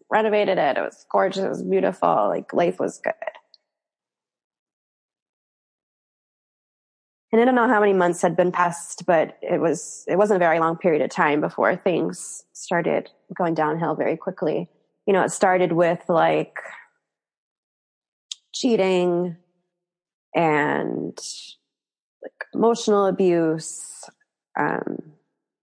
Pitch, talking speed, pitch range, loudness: 180 Hz, 120 wpm, 170-205 Hz, -22 LUFS